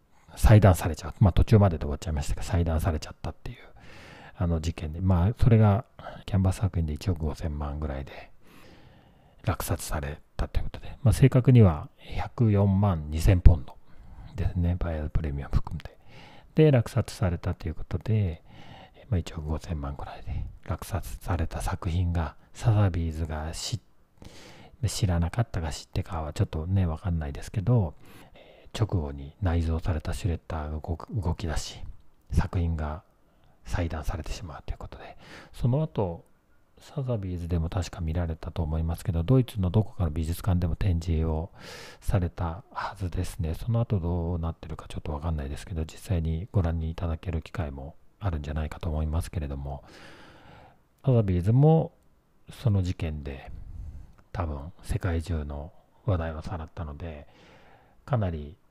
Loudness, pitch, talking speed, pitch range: -28 LUFS, 85 Hz, 335 characters per minute, 80-100 Hz